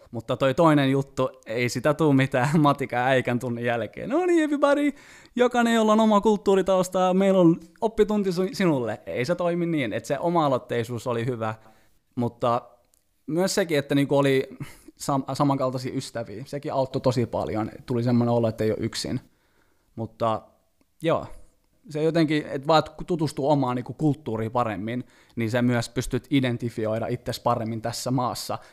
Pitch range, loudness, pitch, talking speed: 120-165 Hz, -24 LUFS, 135 Hz, 150 wpm